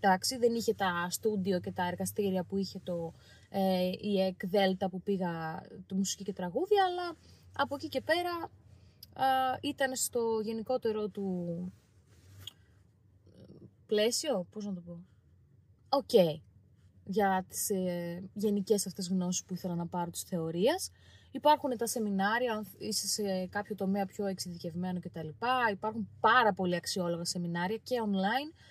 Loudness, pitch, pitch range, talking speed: -32 LUFS, 195 Hz, 175-225 Hz, 140 wpm